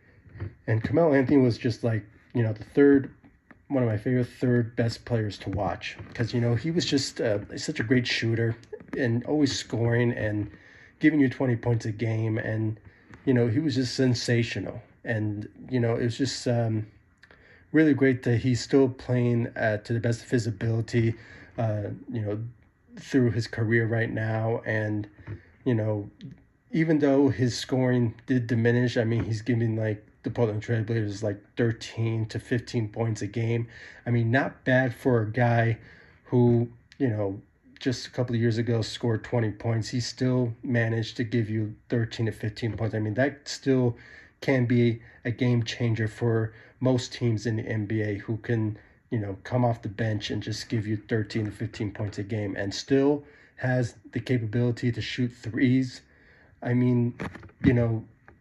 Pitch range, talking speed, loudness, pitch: 110-125 Hz, 180 wpm, -27 LUFS, 115 Hz